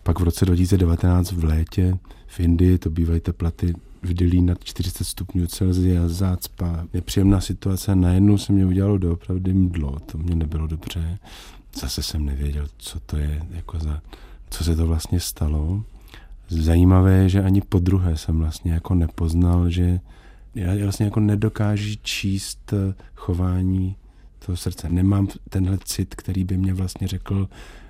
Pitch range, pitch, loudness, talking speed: 85-95 Hz, 90 Hz, -22 LUFS, 155 wpm